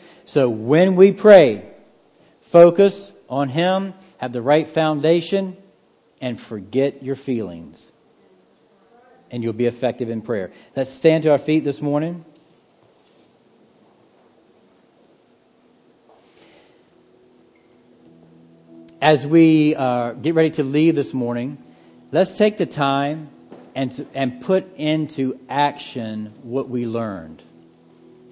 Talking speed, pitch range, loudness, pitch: 105 wpm, 120-160 Hz, -18 LUFS, 140 Hz